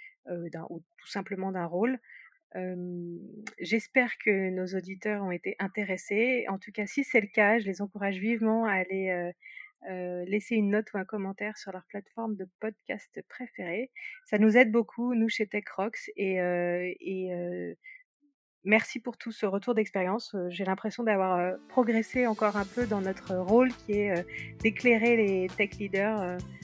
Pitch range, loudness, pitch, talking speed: 185-230 Hz, -29 LUFS, 205 Hz, 165 wpm